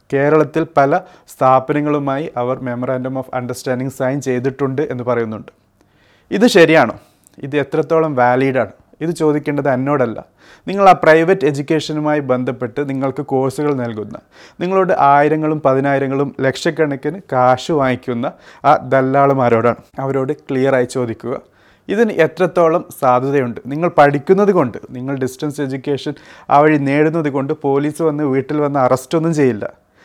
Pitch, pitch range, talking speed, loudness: 140 Hz, 130-155 Hz, 120 wpm, -16 LUFS